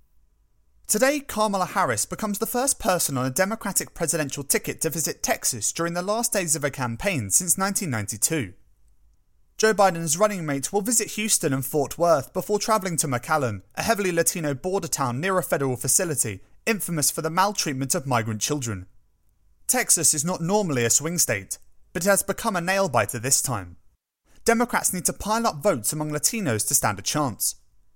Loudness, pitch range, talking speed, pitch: -23 LUFS, 130-200 Hz, 175 wpm, 165 Hz